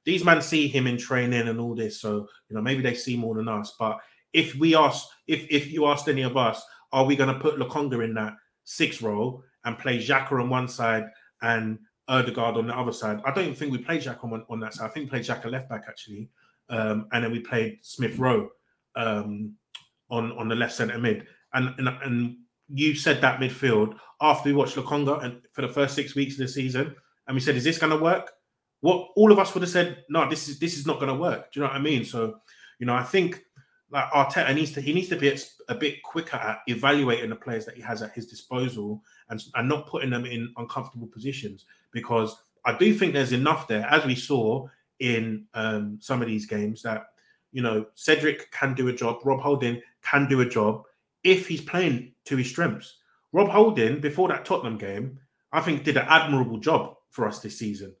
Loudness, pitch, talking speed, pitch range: -25 LUFS, 130 Hz, 225 wpm, 115-145 Hz